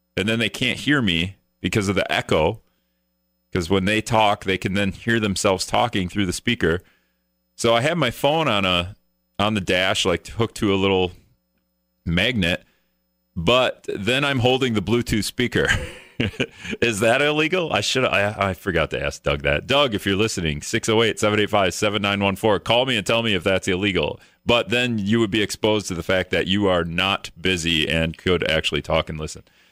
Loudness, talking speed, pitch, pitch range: -21 LUFS, 185 wpm, 100 Hz, 85-115 Hz